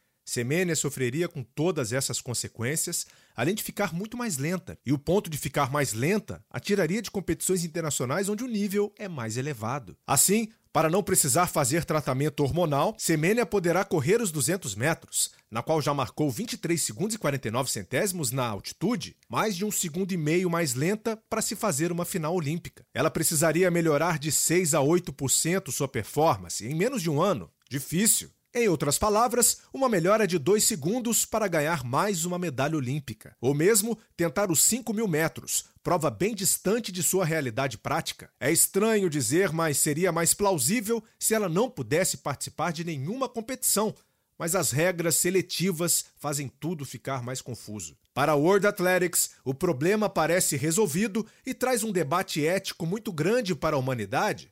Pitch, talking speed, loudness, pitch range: 170 Hz, 170 wpm, -26 LUFS, 145-200 Hz